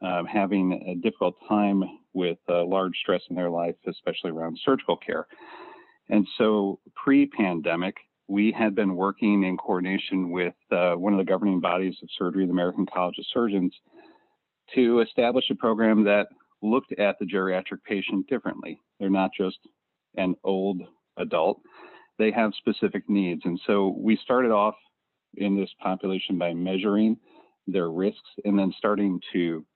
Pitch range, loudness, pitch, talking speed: 90-105 Hz, -26 LUFS, 95 Hz, 155 wpm